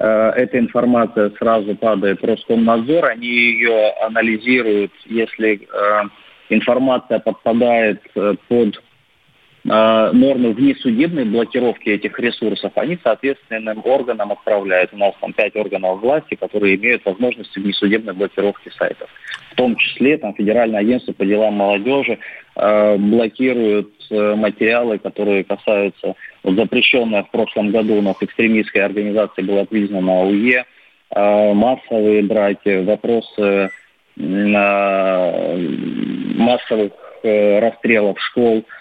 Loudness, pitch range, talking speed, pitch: -16 LUFS, 100-115 Hz, 105 wpm, 110 Hz